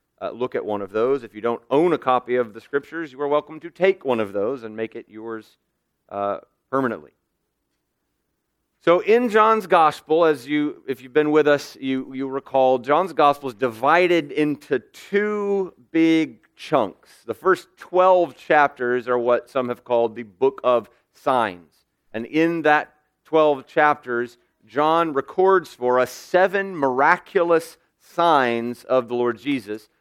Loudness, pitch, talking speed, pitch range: -21 LUFS, 140 Hz, 160 wpm, 120-165 Hz